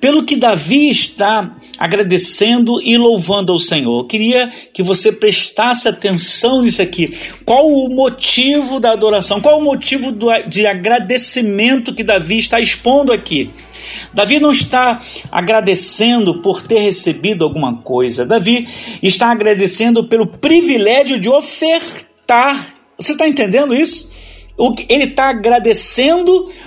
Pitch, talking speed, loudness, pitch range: 230 Hz, 130 wpm, -11 LUFS, 205-265 Hz